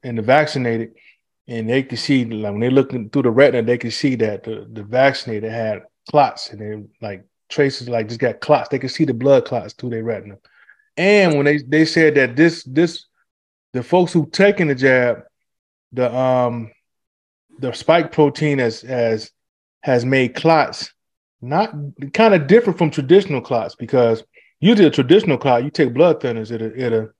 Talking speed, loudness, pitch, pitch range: 190 wpm, -17 LUFS, 125 Hz, 115-150 Hz